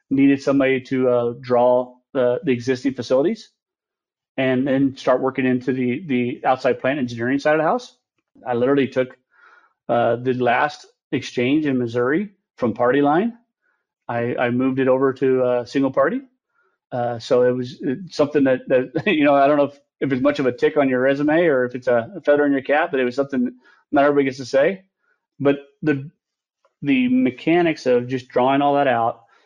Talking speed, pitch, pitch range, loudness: 190 wpm, 135 Hz, 125-150 Hz, -20 LUFS